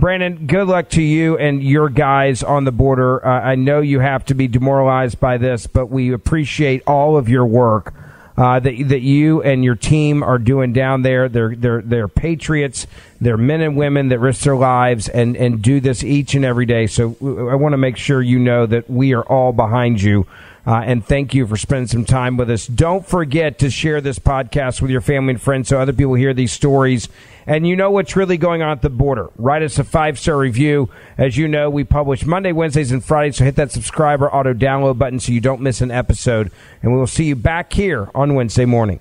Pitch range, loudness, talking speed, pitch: 125-145 Hz, -15 LUFS, 230 wpm, 135 Hz